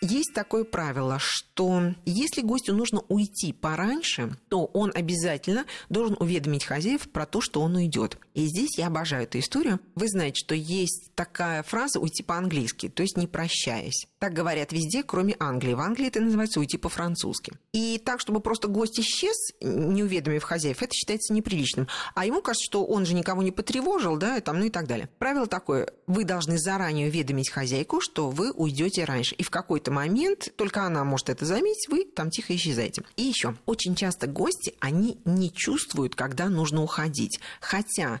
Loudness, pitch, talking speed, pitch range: -27 LUFS, 180 Hz, 175 wpm, 155-215 Hz